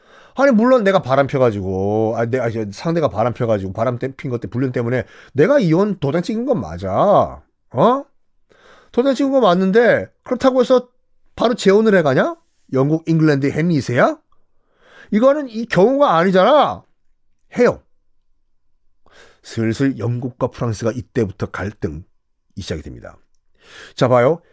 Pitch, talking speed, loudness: 135 Hz, 285 characters per minute, -17 LUFS